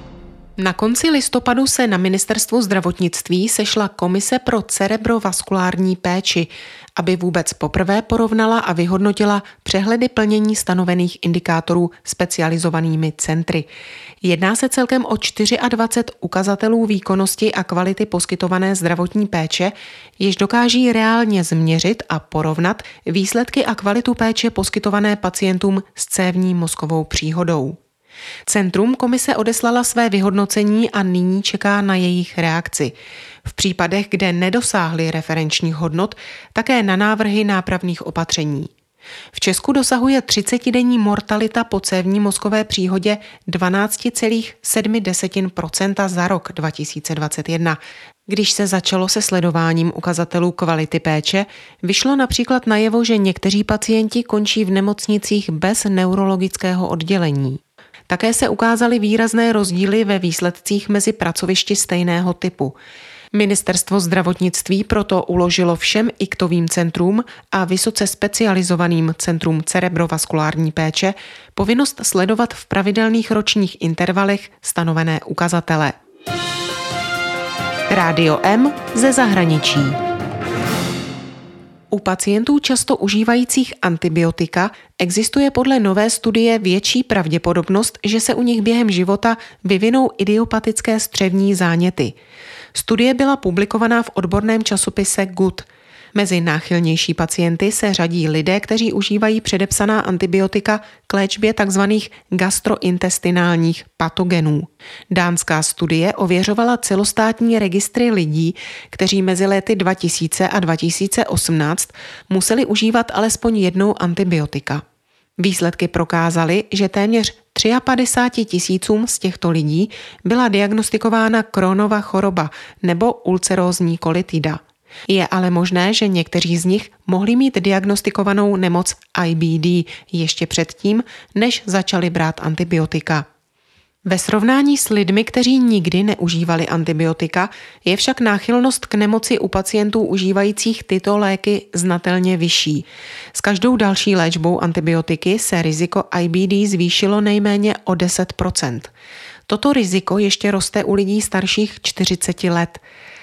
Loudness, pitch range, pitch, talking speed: -17 LUFS, 175-220 Hz, 195 Hz, 110 wpm